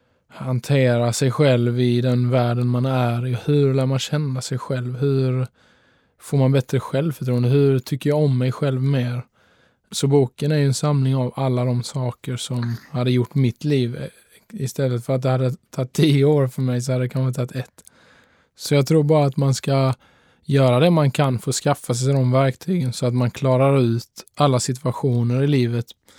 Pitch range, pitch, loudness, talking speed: 125-140 Hz, 130 Hz, -20 LUFS, 190 wpm